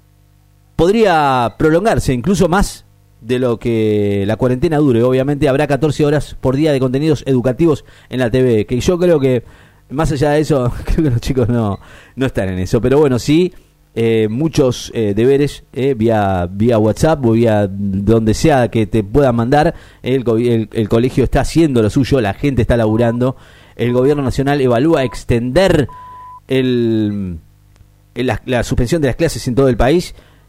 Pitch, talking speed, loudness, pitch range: 125 Hz, 170 wpm, -14 LUFS, 110-145 Hz